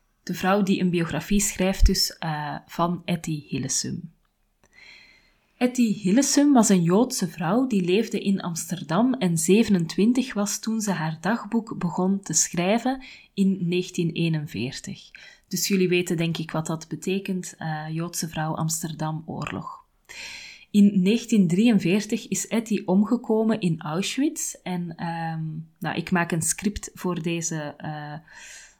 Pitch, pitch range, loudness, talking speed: 185 Hz, 165-205 Hz, -24 LUFS, 130 wpm